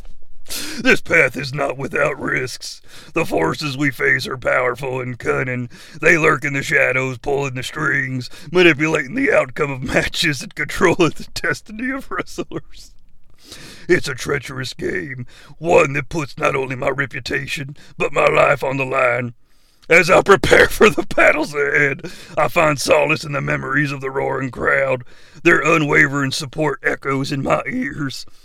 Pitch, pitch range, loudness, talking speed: 140 Hz, 130-150 Hz, -17 LUFS, 155 wpm